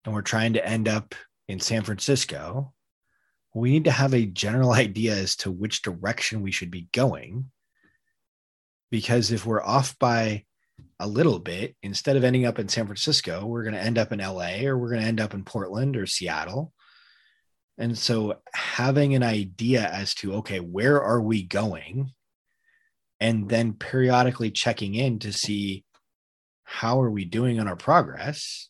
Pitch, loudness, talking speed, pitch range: 115 Hz, -25 LUFS, 170 wpm, 105-130 Hz